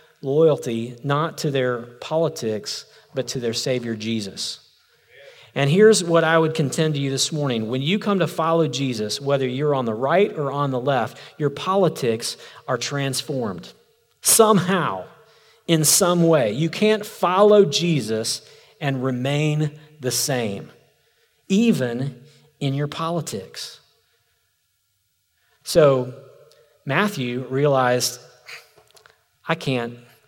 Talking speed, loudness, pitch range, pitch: 120 wpm, -21 LUFS, 125-165 Hz, 140 Hz